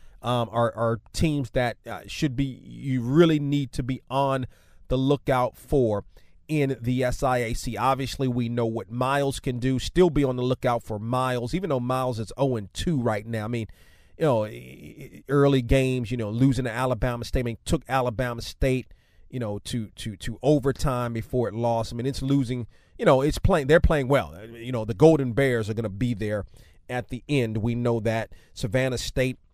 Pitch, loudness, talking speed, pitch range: 125 Hz, -25 LUFS, 185 wpm, 115-135 Hz